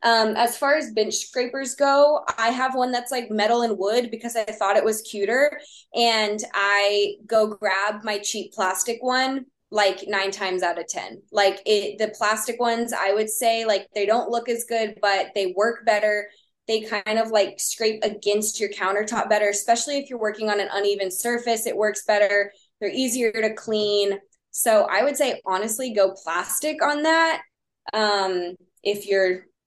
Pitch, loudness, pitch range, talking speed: 215 Hz, -22 LUFS, 205-235 Hz, 180 wpm